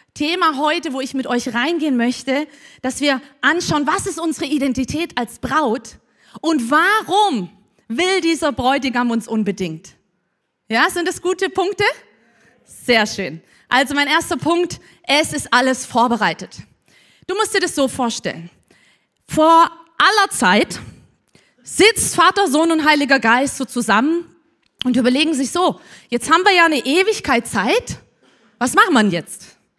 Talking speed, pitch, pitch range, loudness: 145 wpm, 290 Hz, 245-335 Hz, -17 LUFS